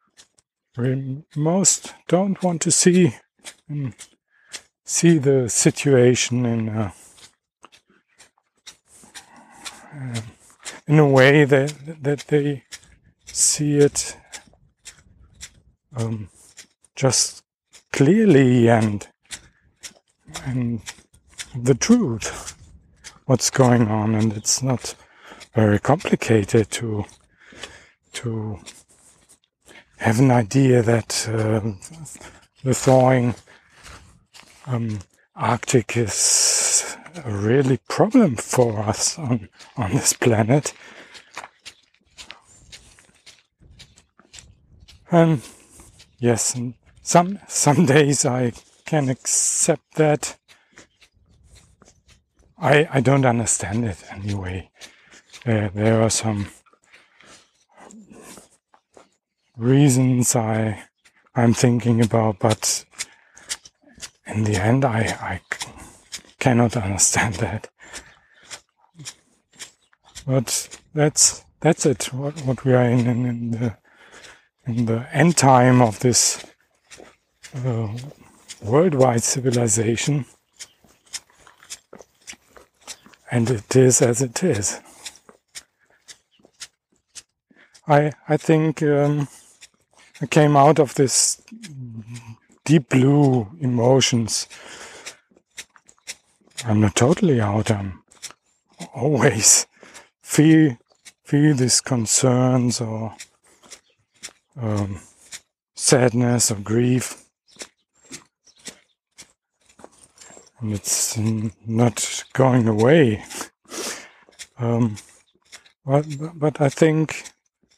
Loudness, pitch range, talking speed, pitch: -19 LUFS, 110-140 Hz, 80 wpm, 120 Hz